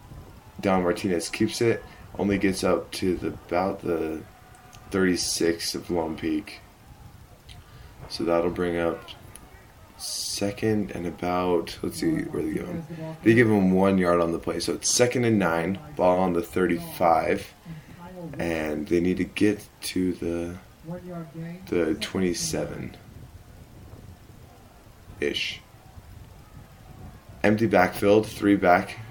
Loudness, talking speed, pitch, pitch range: -25 LUFS, 125 wpm, 95 Hz, 85-115 Hz